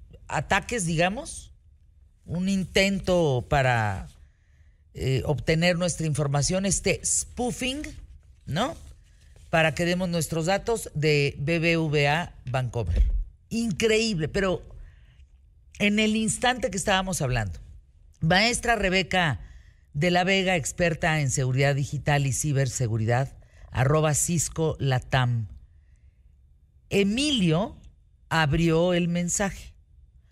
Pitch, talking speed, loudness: 150 Hz, 90 wpm, -25 LUFS